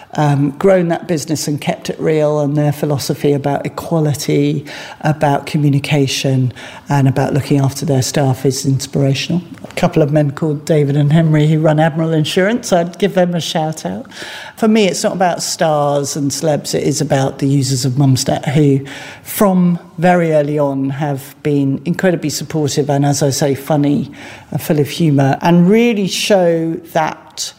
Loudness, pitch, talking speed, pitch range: -15 LUFS, 150 Hz, 170 wpm, 140-170 Hz